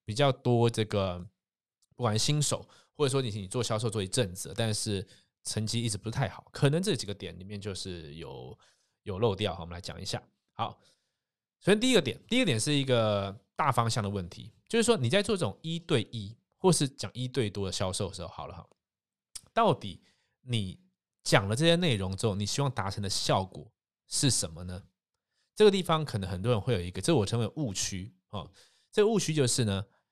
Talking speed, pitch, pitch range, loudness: 295 characters per minute, 110 Hz, 100-135 Hz, -29 LUFS